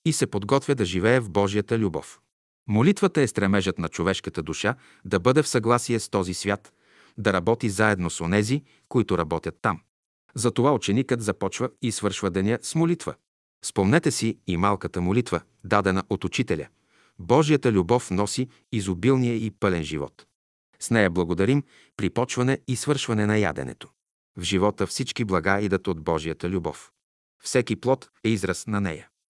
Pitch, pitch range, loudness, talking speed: 105 Hz, 95-125 Hz, -24 LUFS, 155 wpm